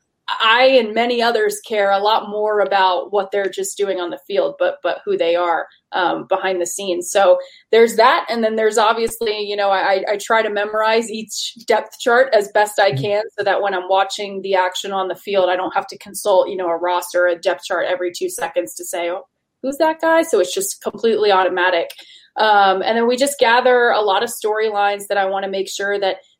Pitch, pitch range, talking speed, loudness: 200 Hz, 185-220 Hz, 225 wpm, -17 LUFS